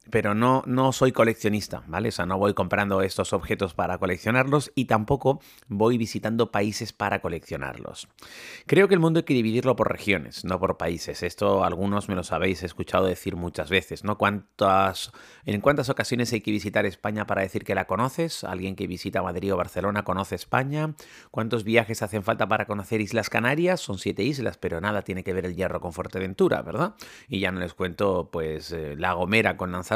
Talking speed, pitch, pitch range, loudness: 195 wpm, 105 Hz, 95-115 Hz, -25 LUFS